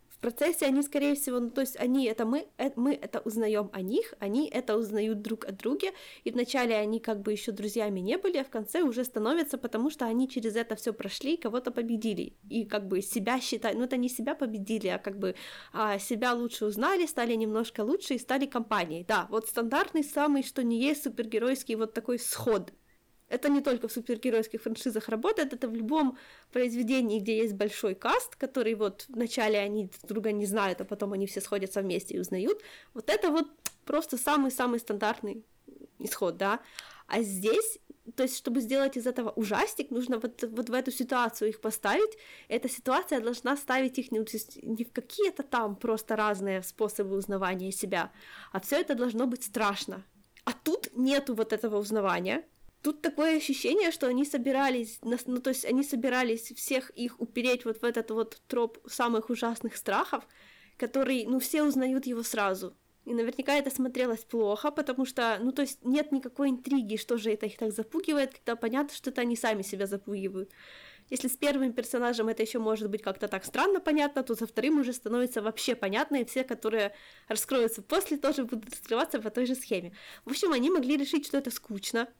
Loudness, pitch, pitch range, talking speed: -31 LUFS, 240 Hz, 220-270 Hz, 185 wpm